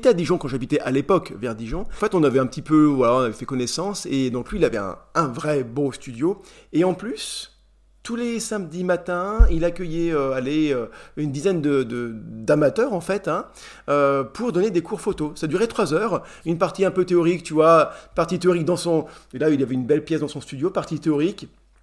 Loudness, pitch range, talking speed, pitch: -22 LUFS, 140-180 Hz, 230 wpm, 155 Hz